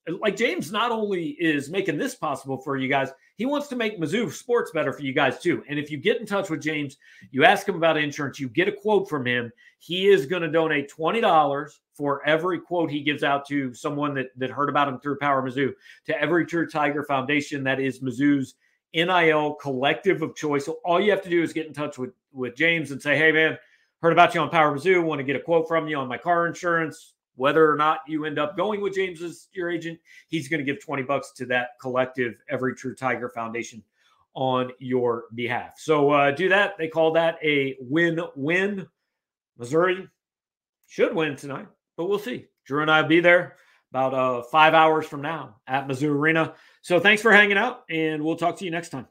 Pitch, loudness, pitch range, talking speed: 155 Hz, -23 LUFS, 140-170 Hz, 220 wpm